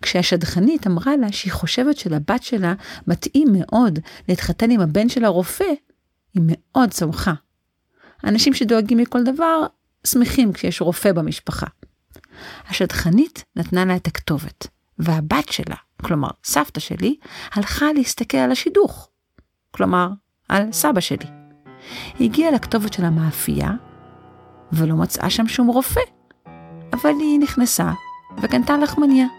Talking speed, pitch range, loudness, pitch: 120 wpm, 170-265 Hz, -19 LUFS, 210 Hz